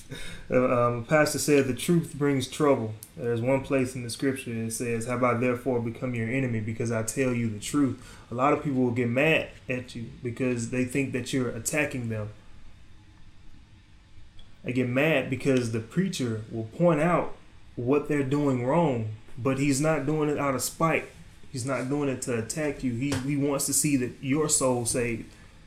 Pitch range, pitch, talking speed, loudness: 115-140 Hz, 125 Hz, 190 wpm, -27 LUFS